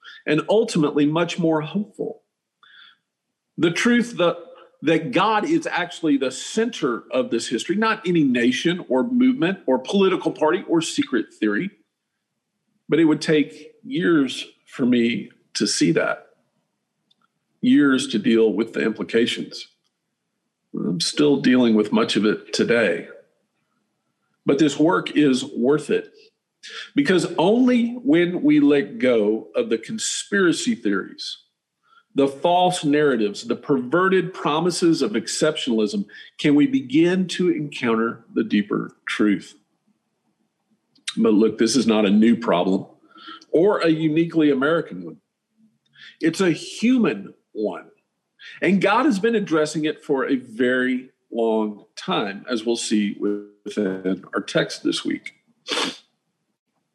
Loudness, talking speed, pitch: -21 LUFS, 125 wpm, 165 Hz